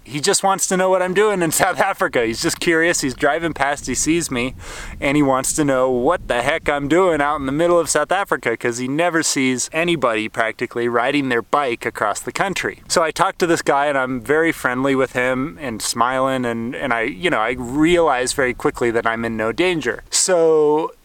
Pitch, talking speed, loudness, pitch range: 140 Hz, 220 wpm, -18 LUFS, 125-165 Hz